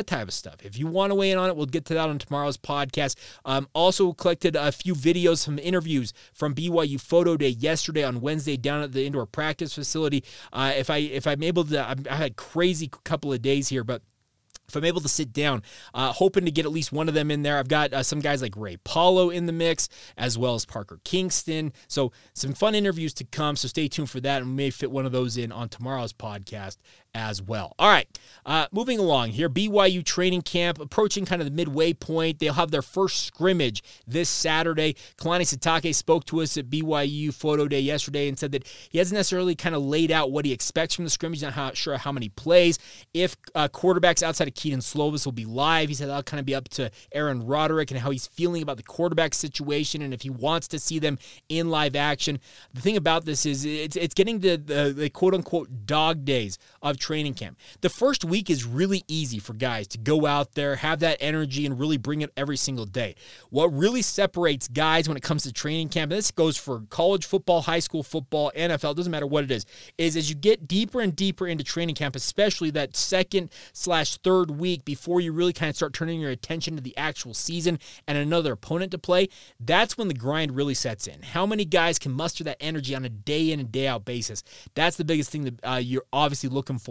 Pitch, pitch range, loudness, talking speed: 150 Hz, 135-170 Hz, -25 LUFS, 230 wpm